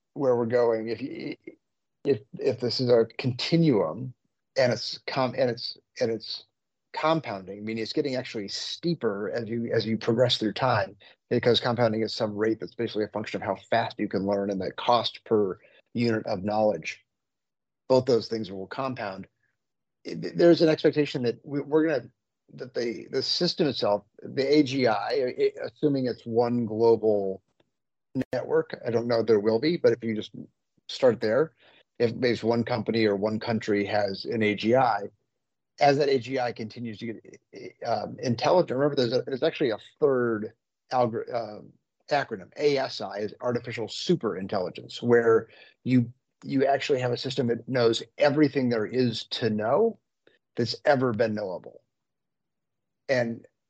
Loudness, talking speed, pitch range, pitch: -26 LUFS, 155 wpm, 110-135 Hz, 120 Hz